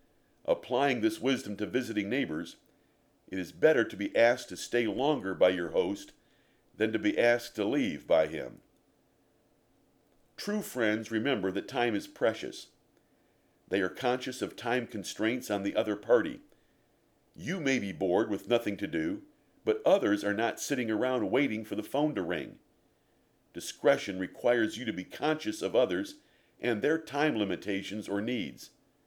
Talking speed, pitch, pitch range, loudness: 160 wpm, 120 Hz, 105-155 Hz, -31 LUFS